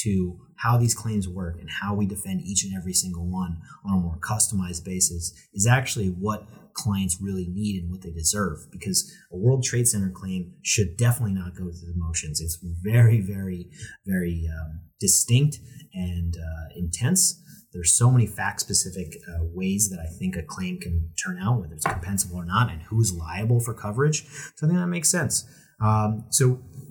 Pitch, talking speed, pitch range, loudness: 95 Hz, 185 wpm, 90-115 Hz, -24 LUFS